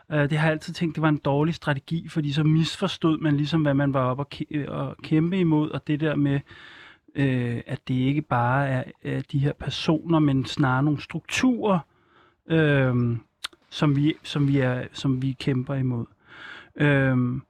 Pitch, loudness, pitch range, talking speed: 145 Hz, -24 LUFS, 135-155 Hz, 160 wpm